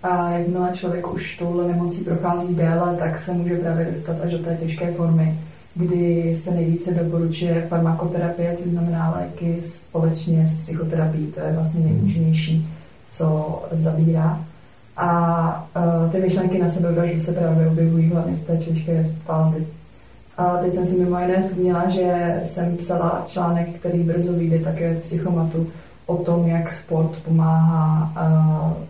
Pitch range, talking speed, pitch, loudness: 165-175 Hz, 150 wpm, 170 Hz, -21 LUFS